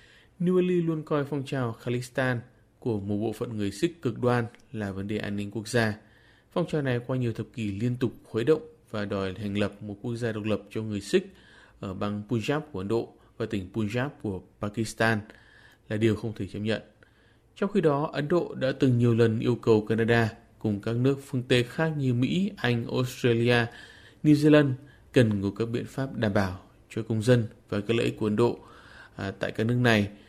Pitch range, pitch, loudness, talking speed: 105-130 Hz, 115 Hz, -28 LUFS, 210 wpm